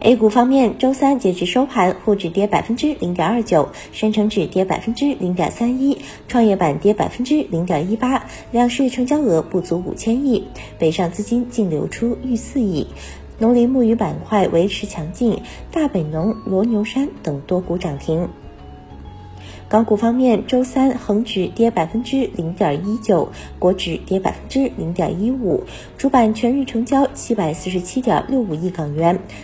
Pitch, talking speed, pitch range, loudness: 210 Hz, 255 characters per minute, 175-245 Hz, -18 LUFS